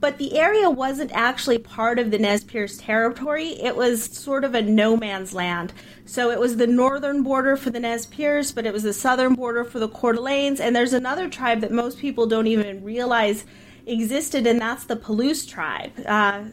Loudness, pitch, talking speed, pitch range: -22 LUFS, 240 Hz, 205 wpm, 225-265 Hz